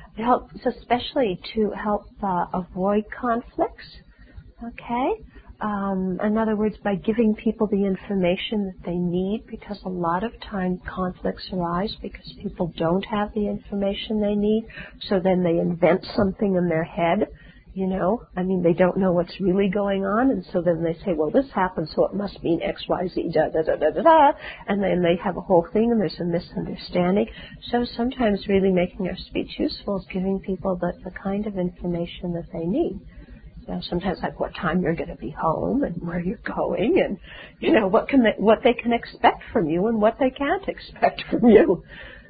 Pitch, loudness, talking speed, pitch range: 195 Hz, -23 LUFS, 195 wpm, 180-220 Hz